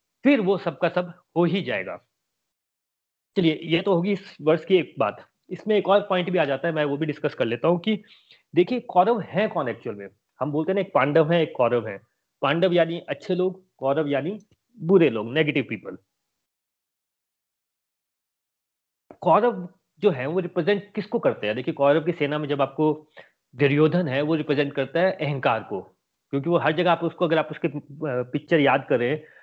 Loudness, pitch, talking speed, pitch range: -23 LUFS, 165 Hz, 190 wpm, 145-185 Hz